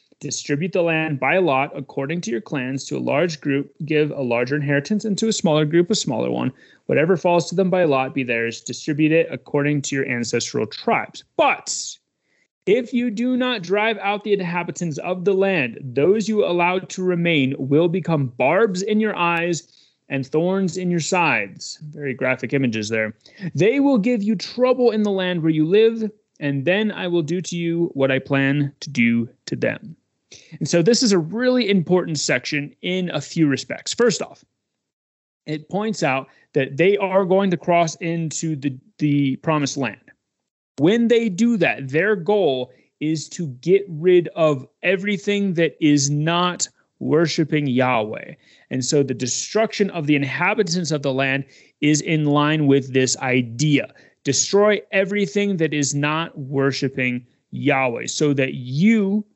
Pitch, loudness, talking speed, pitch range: 160 Hz, -20 LUFS, 170 wpm, 140-190 Hz